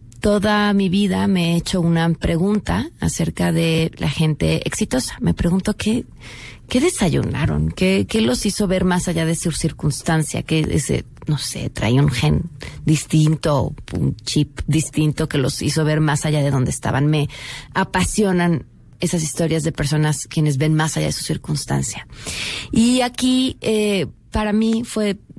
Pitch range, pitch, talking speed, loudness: 150-195 Hz, 160 Hz, 160 wpm, -19 LUFS